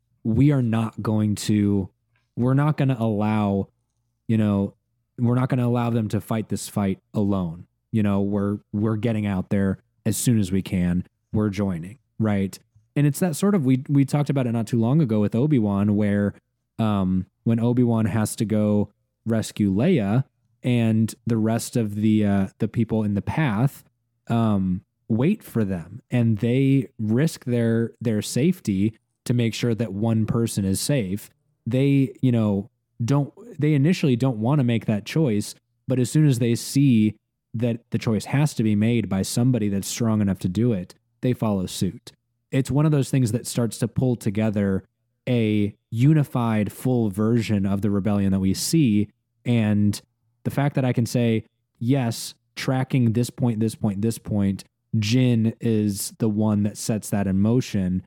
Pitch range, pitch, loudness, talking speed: 105-125 Hz, 115 Hz, -23 LUFS, 180 wpm